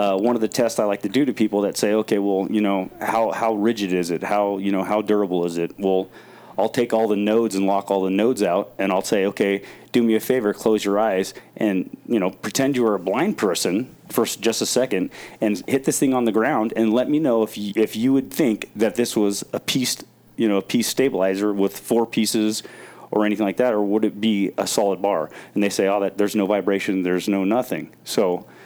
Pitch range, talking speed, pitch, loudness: 100-110 Hz, 245 wpm, 105 Hz, -21 LUFS